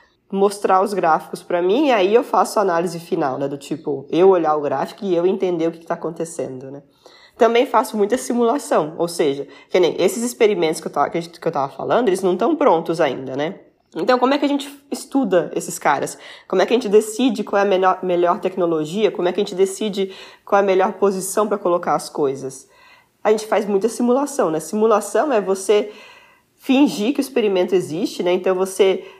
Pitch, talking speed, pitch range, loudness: 195 Hz, 210 wpm, 170-220 Hz, -19 LUFS